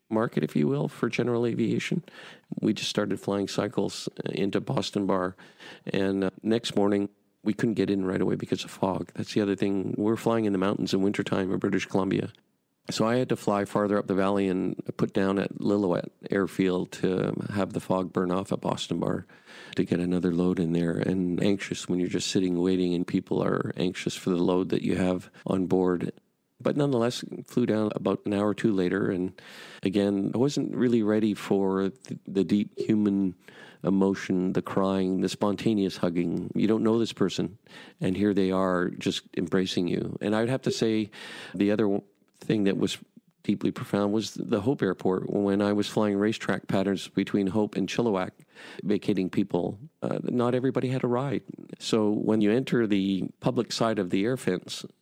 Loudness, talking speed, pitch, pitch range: -27 LUFS, 190 wpm, 100 Hz, 95-105 Hz